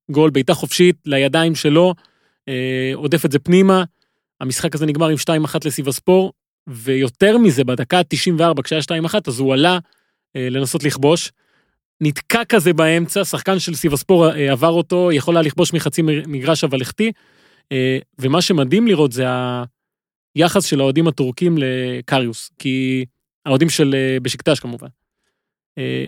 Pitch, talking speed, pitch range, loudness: 155 Hz, 145 wpm, 135-175 Hz, -16 LUFS